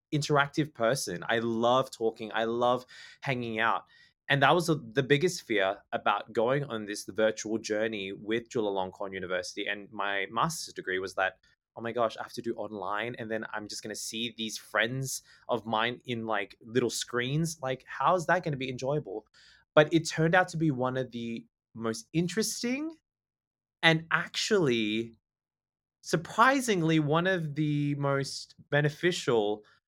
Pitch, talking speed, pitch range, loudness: 120 Hz, 165 wpm, 110-150 Hz, -30 LUFS